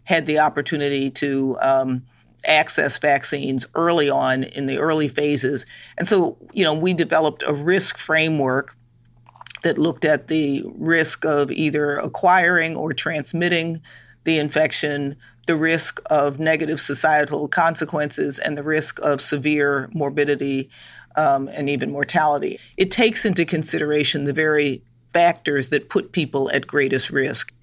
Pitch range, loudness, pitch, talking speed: 140-160 Hz, -20 LUFS, 150 Hz, 135 wpm